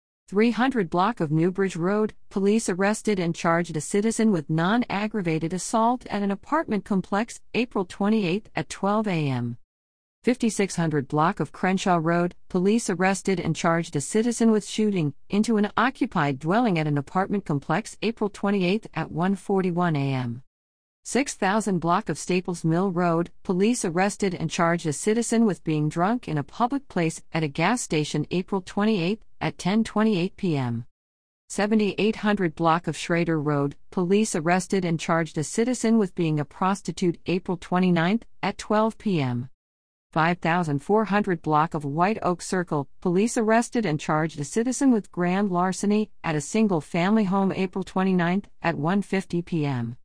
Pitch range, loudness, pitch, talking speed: 160-210 Hz, -24 LUFS, 185 Hz, 145 wpm